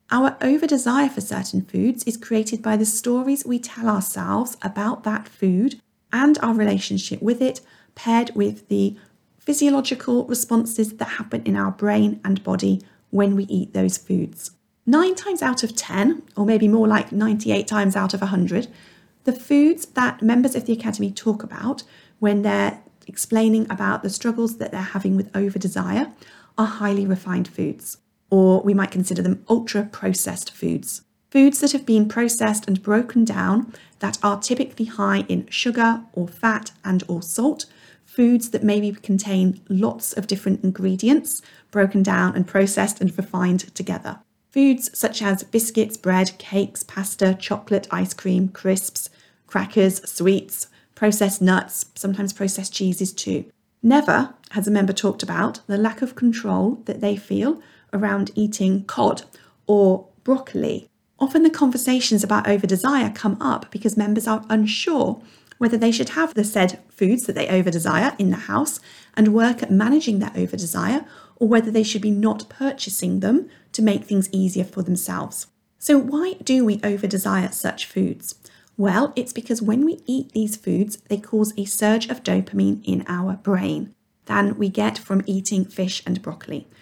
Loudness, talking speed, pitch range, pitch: -21 LUFS, 160 wpm, 195-235 Hz, 210 Hz